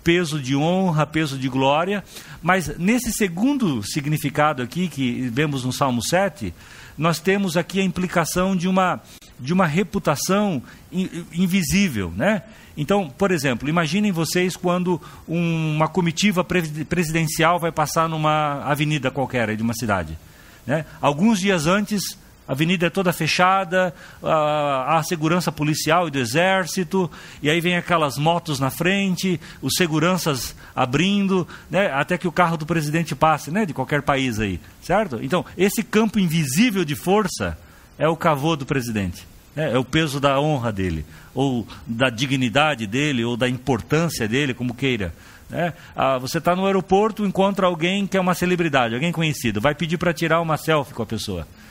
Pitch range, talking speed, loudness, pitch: 135-180 Hz, 155 wpm, -21 LUFS, 160 Hz